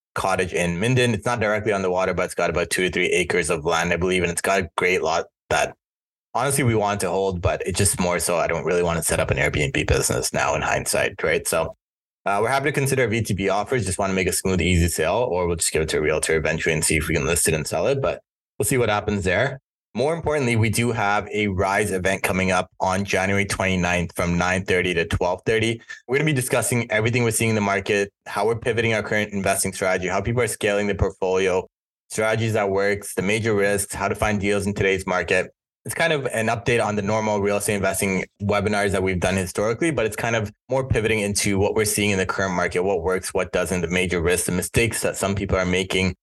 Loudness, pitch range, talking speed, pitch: -22 LUFS, 95-110 Hz, 250 wpm, 100 Hz